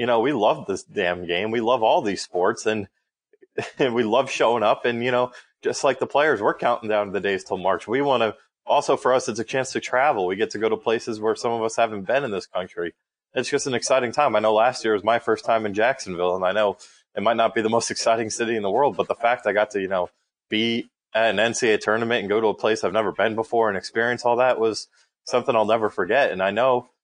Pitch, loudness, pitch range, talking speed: 115 Hz, -22 LUFS, 110-120 Hz, 270 wpm